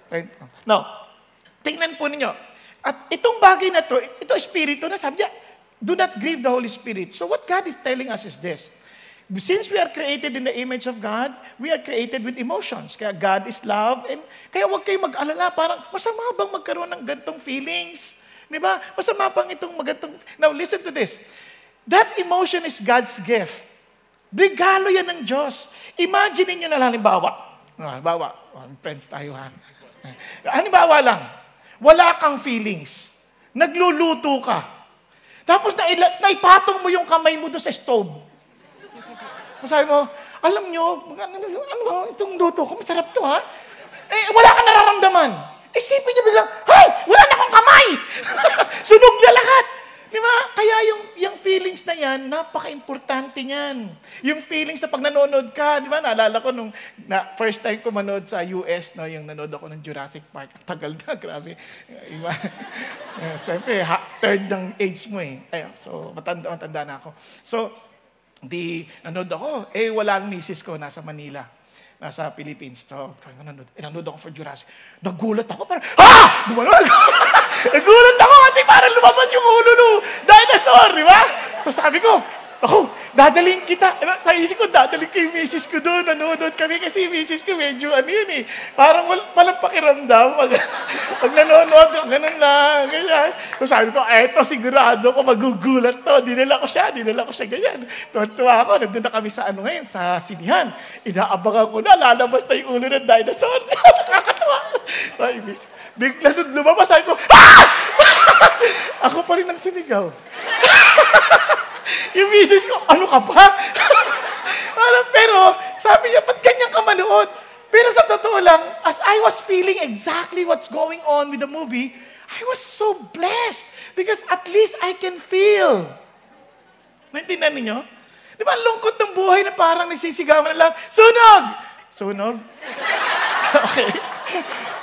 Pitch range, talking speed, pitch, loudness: 230-370 Hz, 160 wpm, 305 Hz, -14 LUFS